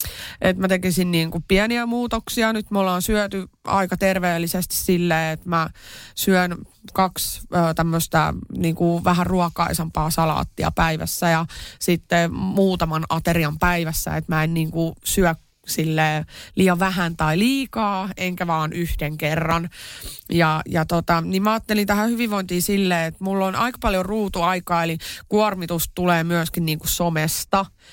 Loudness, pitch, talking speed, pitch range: -21 LUFS, 175 Hz, 135 wpm, 165-190 Hz